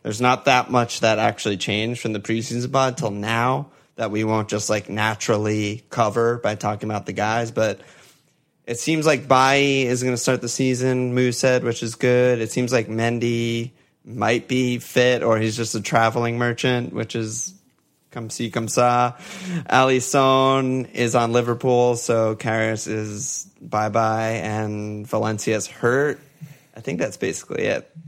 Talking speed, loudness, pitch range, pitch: 165 wpm, -21 LUFS, 110-130 Hz, 120 Hz